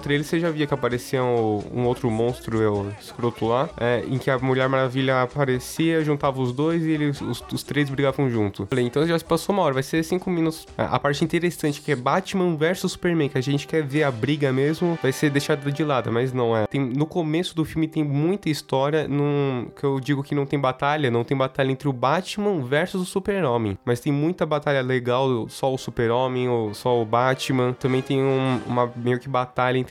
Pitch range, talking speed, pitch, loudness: 125-155 Hz, 220 wpm, 140 Hz, -23 LUFS